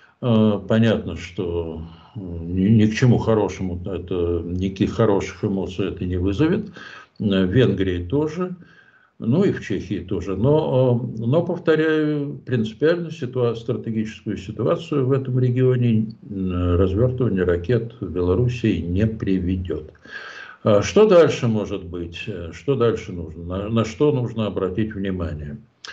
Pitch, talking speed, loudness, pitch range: 110 Hz, 120 wpm, -21 LUFS, 95-125 Hz